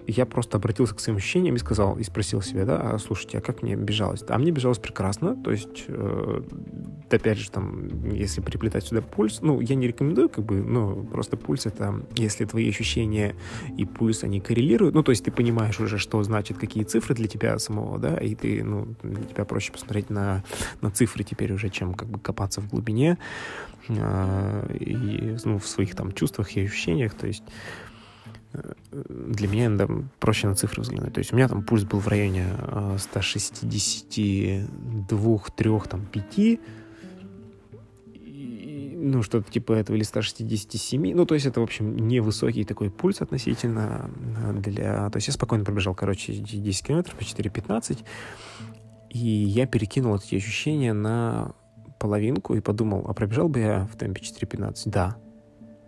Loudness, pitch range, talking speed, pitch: -26 LUFS, 105-115 Hz, 165 wpm, 110 Hz